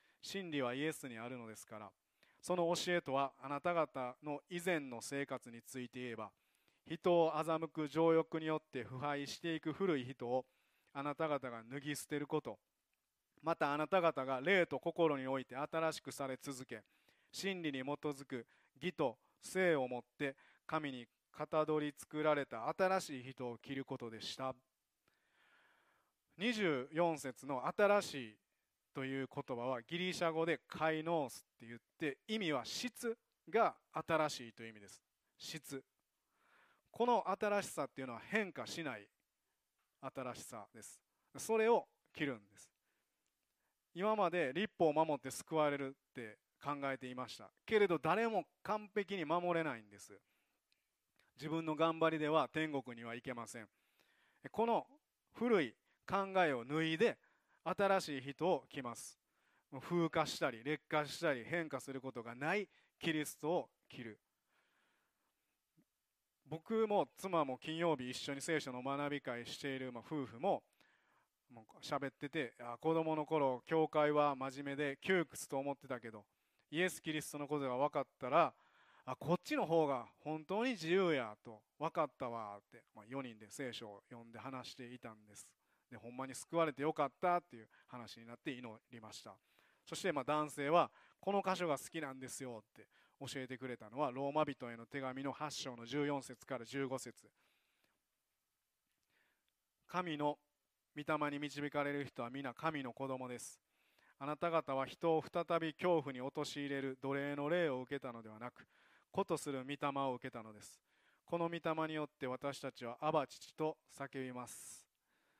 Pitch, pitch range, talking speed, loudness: 145 Hz, 130-160 Hz, 285 characters per minute, -40 LUFS